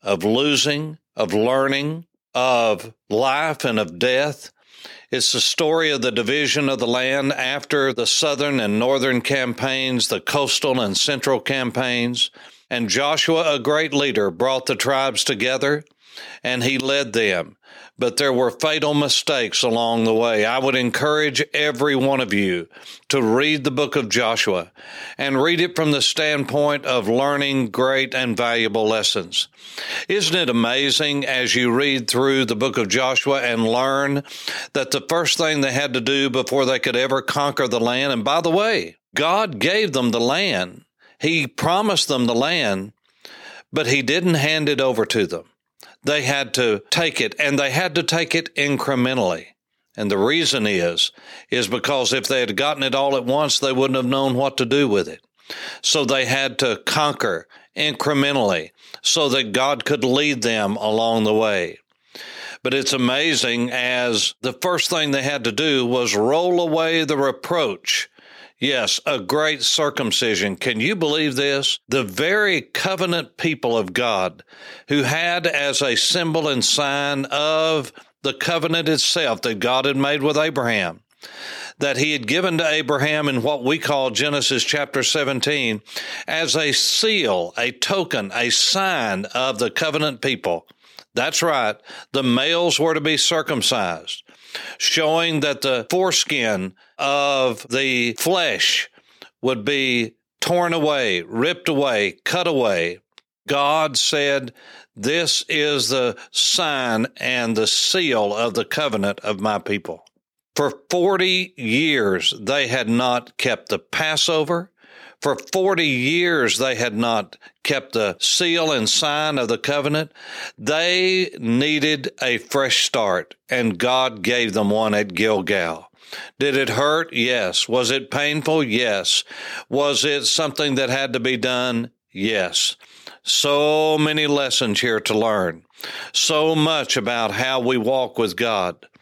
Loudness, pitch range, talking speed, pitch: -19 LUFS, 125-150 Hz, 150 wpm, 135 Hz